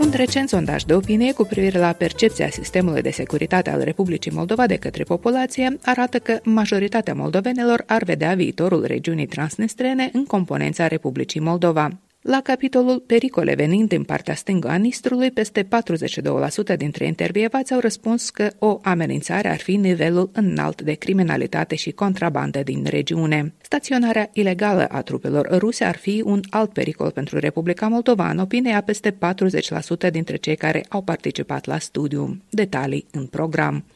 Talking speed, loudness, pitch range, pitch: 150 wpm, -21 LUFS, 165-225 Hz, 190 Hz